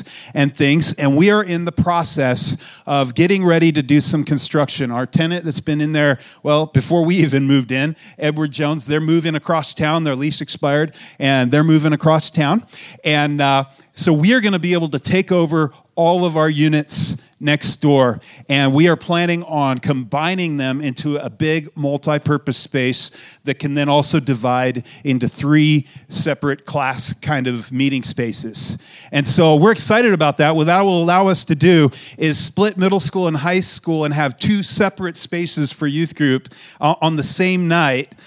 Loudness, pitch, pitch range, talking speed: -16 LUFS, 150 Hz, 140-170 Hz, 185 wpm